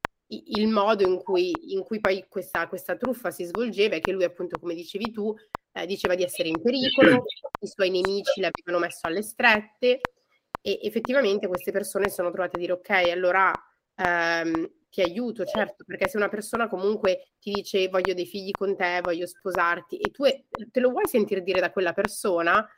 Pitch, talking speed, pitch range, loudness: 195 Hz, 185 wpm, 180-215 Hz, -25 LUFS